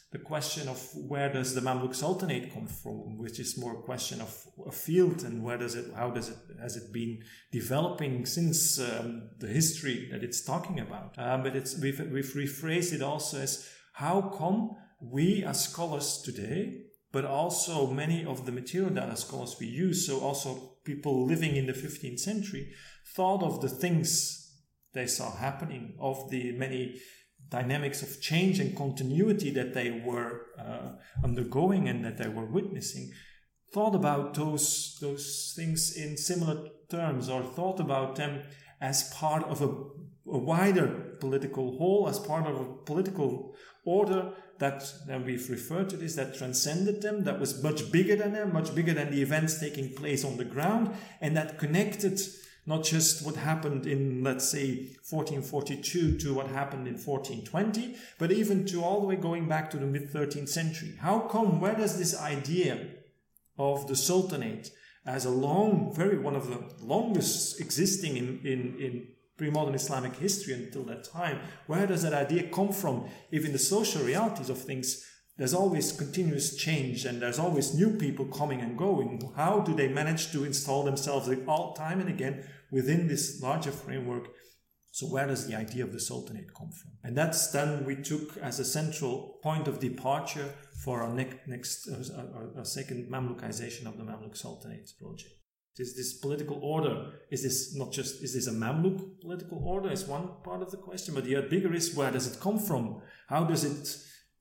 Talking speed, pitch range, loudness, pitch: 180 wpm, 130-170 Hz, -31 LUFS, 145 Hz